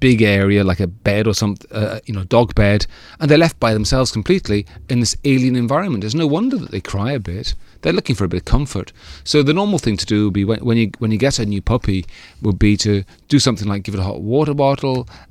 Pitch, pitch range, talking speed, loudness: 110 Hz, 100-130 Hz, 260 wpm, -17 LUFS